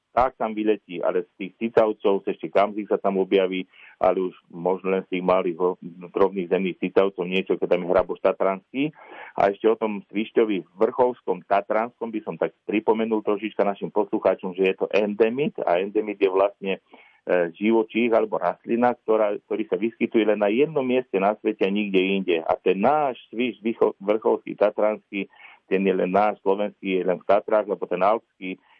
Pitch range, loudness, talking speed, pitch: 95-110 Hz, -23 LUFS, 180 wpm, 105 Hz